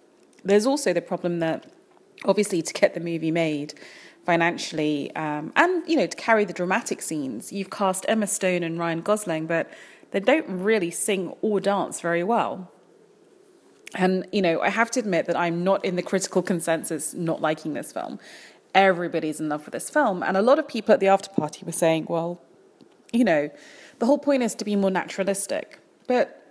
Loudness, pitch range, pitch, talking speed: -24 LUFS, 170-230 Hz, 190 Hz, 190 wpm